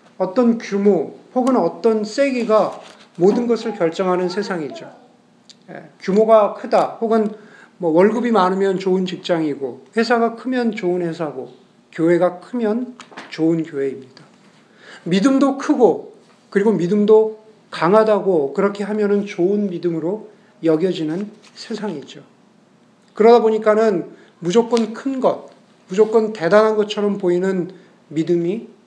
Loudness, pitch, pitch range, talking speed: -18 LUFS, 210 Hz, 180-225 Hz, 265 characters per minute